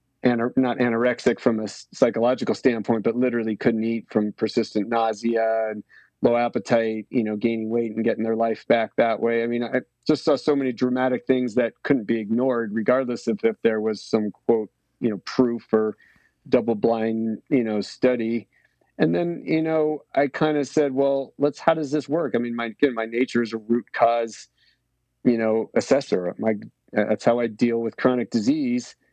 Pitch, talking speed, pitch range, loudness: 120 Hz, 185 wpm, 115-130 Hz, -23 LUFS